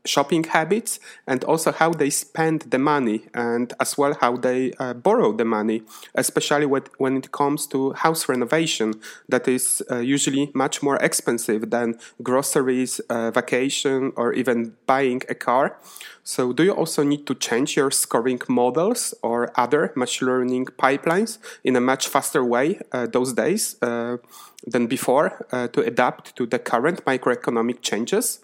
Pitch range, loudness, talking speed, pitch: 120-145 Hz, -22 LUFS, 160 wpm, 130 Hz